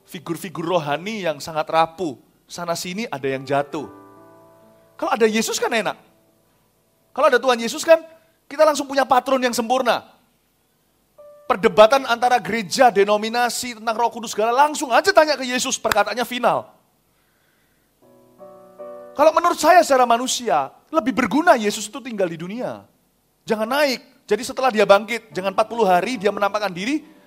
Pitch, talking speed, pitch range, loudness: 235 Hz, 145 wpm, 195-275 Hz, -19 LUFS